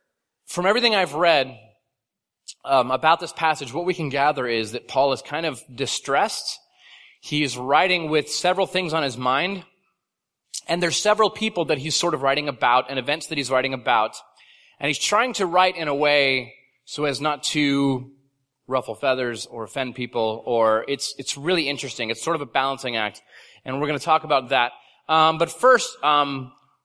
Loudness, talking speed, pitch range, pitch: -22 LUFS, 200 wpm, 130-165 Hz, 145 Hz